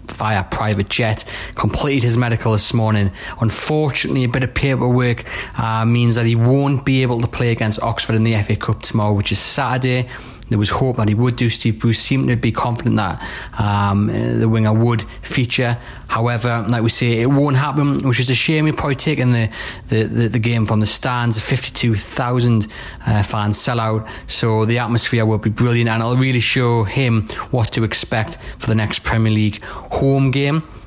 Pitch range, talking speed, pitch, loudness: 110-125 Hz, 195 wpm, 115 Hz, -17 LUFS